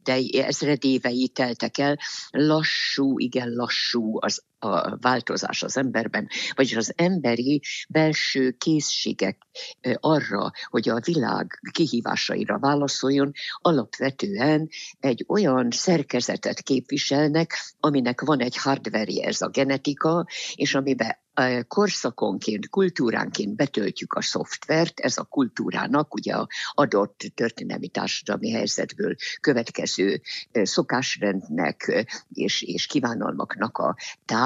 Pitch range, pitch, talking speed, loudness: 125-155 Hz, 135 Hz, 100 wpm, -24 LUFS